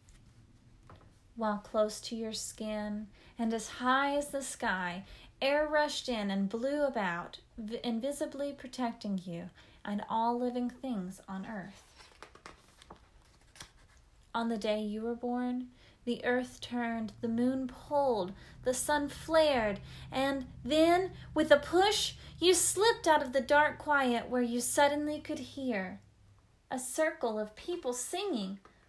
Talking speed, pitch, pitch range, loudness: 135 wpm, 245 Hz, 215-285 Hz, -32 LUFS